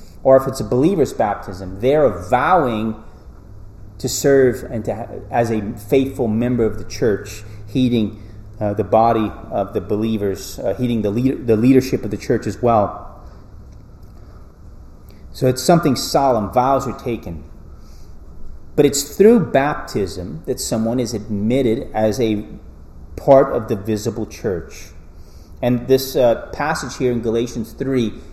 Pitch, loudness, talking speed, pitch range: 110 Hz, -18 LUFS, 140 wpm, 100-125 Hz